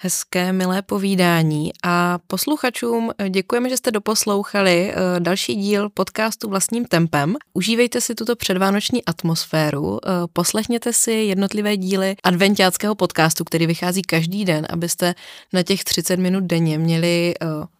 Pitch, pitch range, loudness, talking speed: 185 Hz, 175-210 Hz, -19 LUFS, 120 wpm